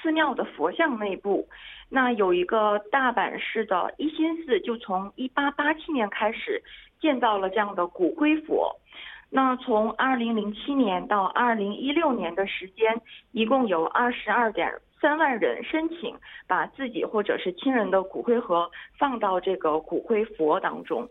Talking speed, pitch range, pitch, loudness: 240 characters per minute, 205-295 Hz, 240 Hz, -25 LUFS